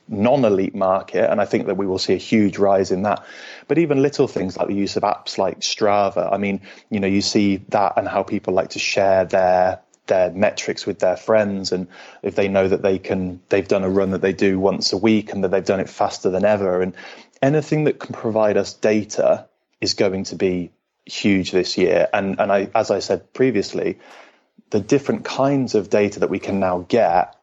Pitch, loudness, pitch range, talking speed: 100 Hz, -19 LUFS, 95-110 Hz, 220 wpm